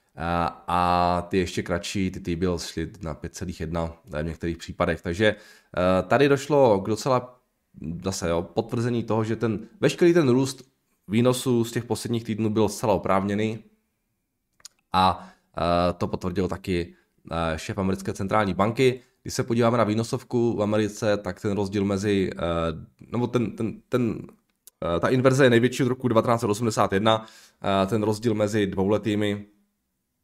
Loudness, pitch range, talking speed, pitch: -24 LUFS, 90-115 Hz, 140 wpm, 105 Hz